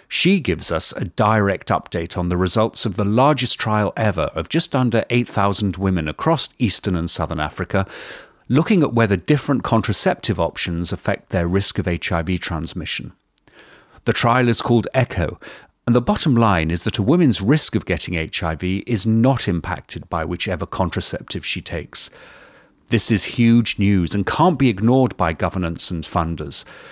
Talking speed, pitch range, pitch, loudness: 165 wpm, 90-120 Hz, 100 Hz, -19 LUFS